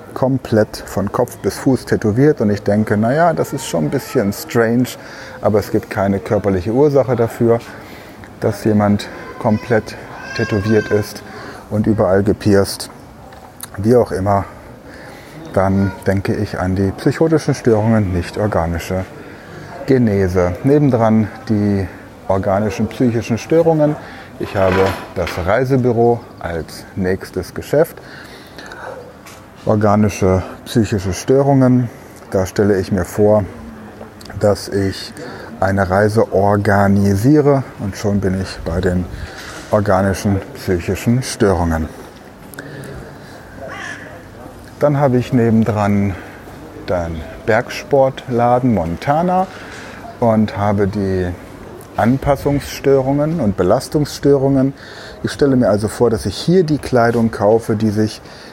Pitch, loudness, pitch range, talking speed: 105 Hz, -16 LUFS, 100-125 Hz, 110 wpm